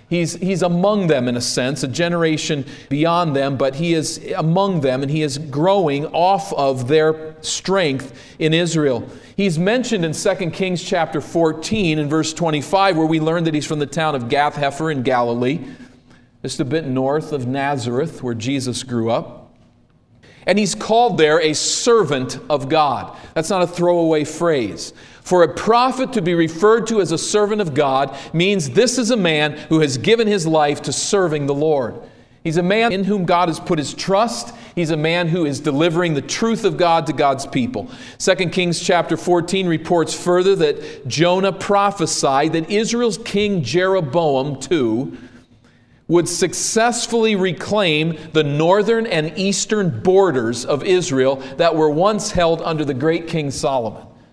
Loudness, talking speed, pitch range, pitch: -18 LUFS, 170 wpm, 150-190 Hz, 165 Hz